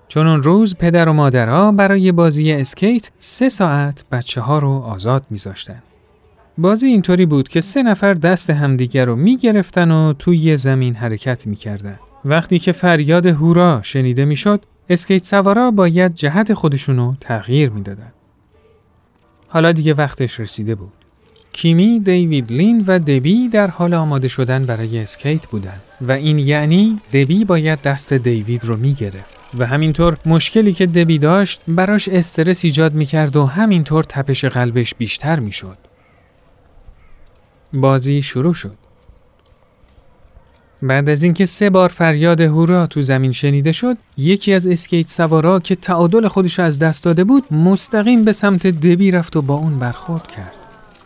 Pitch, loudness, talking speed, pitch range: 155 Hz, -14 LUFS, 145 wpm, 130-180 Hz